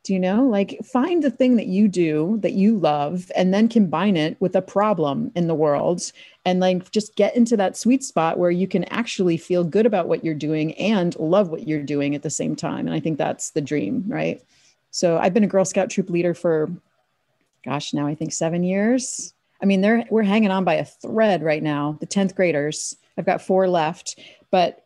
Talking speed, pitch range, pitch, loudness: 220 wpm, 160-210 Hz, 185 Hz, -21 LUFS